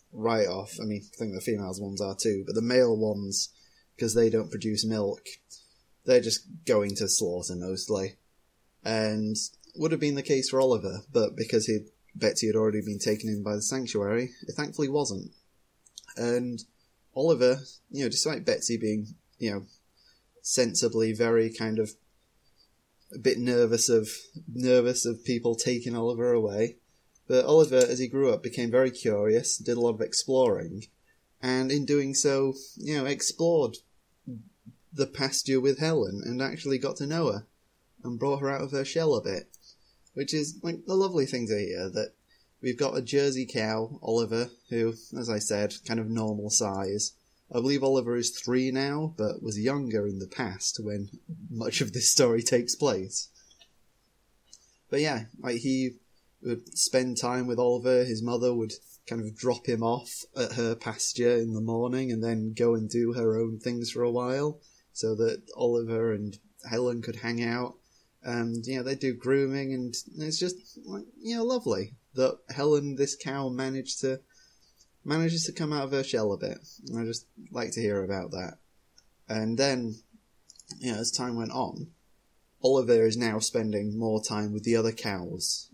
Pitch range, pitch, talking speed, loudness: 110-135 Hz, 120 Hz, 175 wpm, -28 LUFS